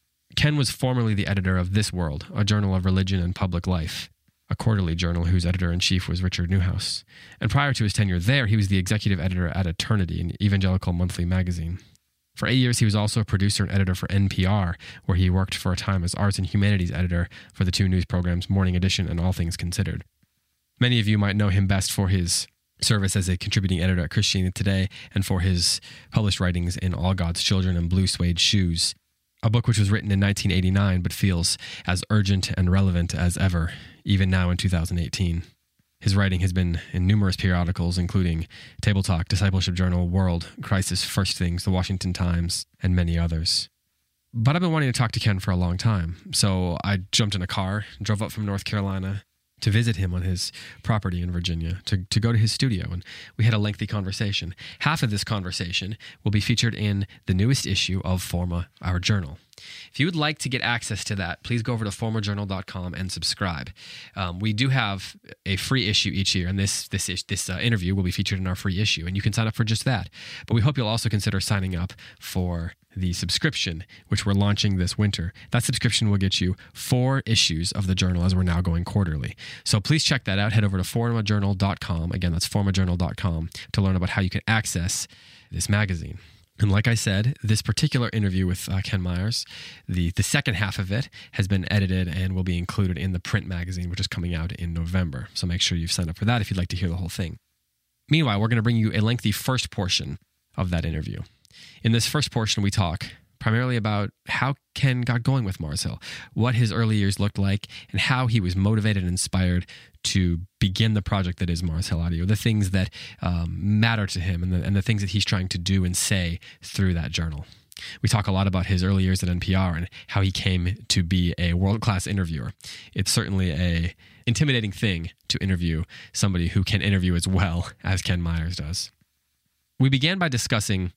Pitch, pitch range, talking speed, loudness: 95 Hz, 90-110 Hz, 215 wpm, -24 LUFS